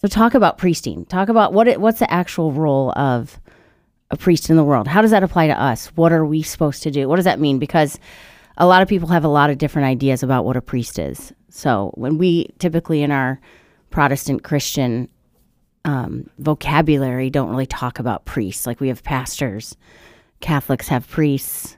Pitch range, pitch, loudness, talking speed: 130-165 Hz, 145 Hz, -18 LUFS, 200 wpm